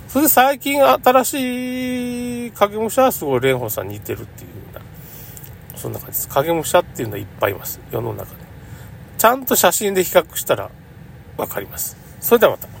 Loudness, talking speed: -18 LUFS, 370 characters per minute